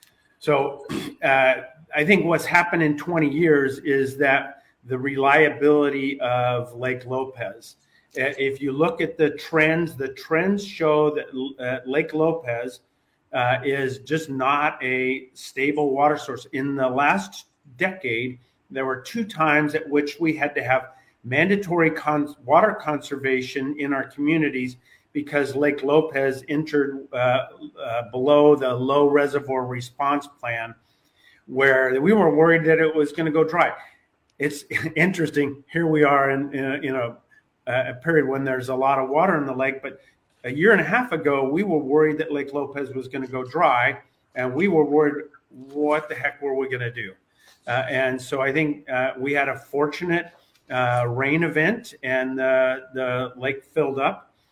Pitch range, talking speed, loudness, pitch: 130-155 Hz, 165 wpm, -22 LUFS, 140 Hz